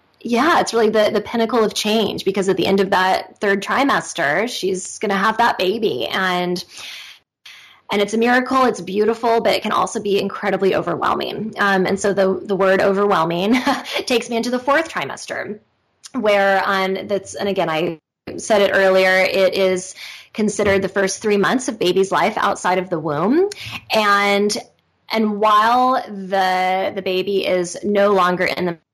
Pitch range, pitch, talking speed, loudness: 190-220 Hz, 200 Hz, 175 wpm, -18 LUFS